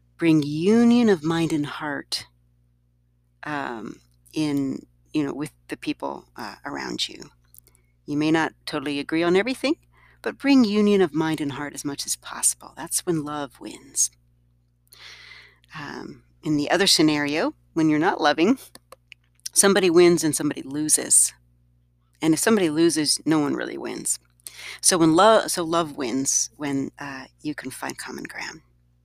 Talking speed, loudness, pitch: 150 wpm, -22 LUFS, 150 Hz